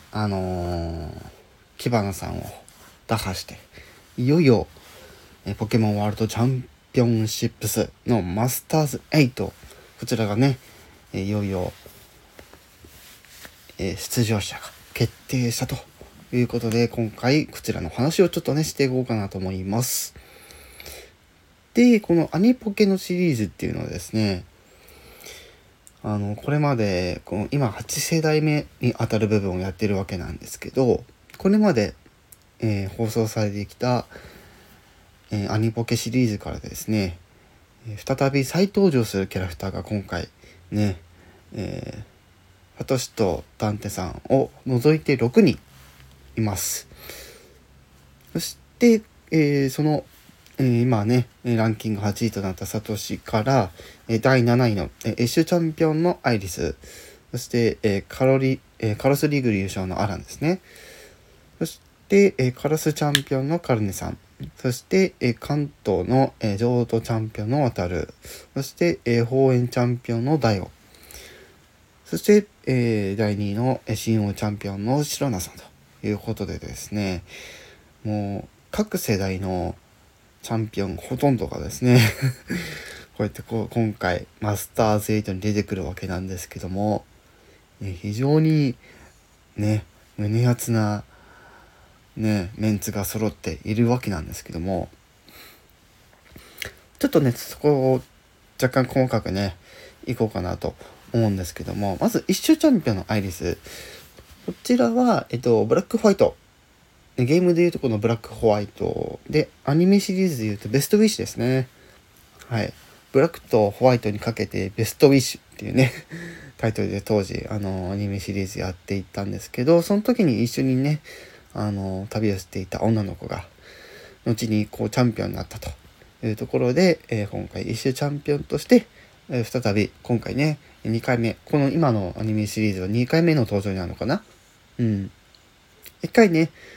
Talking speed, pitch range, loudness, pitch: 295 characters per minute, 100-130 Hz, -23 LUFS, 110 Hz